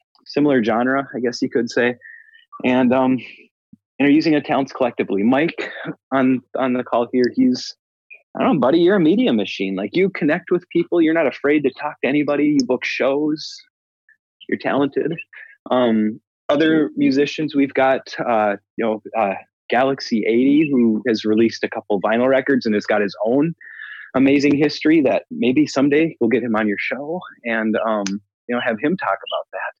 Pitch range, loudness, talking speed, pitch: 115-150 Hz, -19 LUFS, 180 wpm, 135 Hz